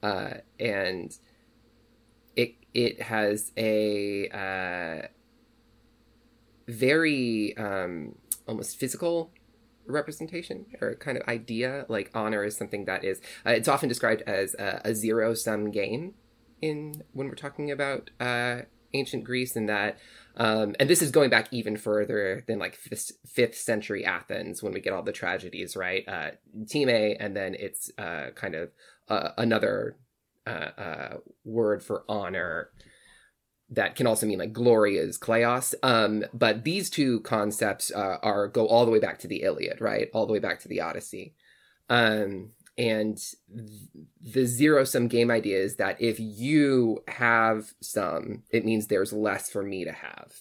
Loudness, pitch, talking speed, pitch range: -27 LUFS, 115 Hz, 155 wpm, 105-125 Hz